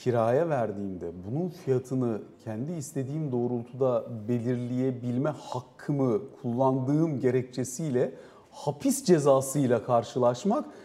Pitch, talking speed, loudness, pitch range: 130 Hz, 75 wpm, -28 LUFS, 120-140 Hz